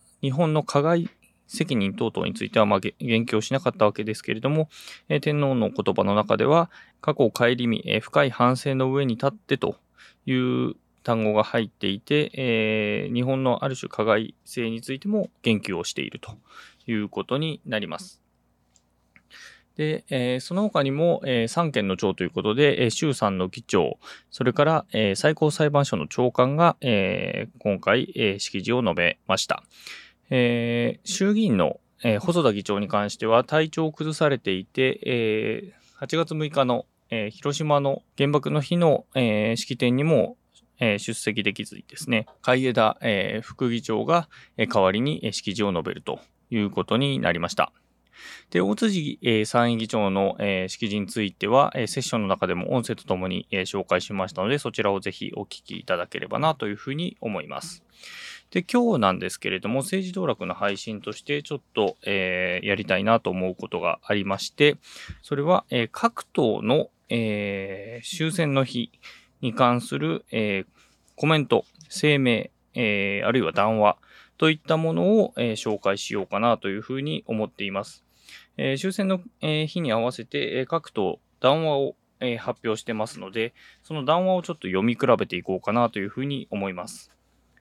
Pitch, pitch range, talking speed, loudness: 120 Hz, 105-150 Hz, 305 characters per minute, -24 LUFS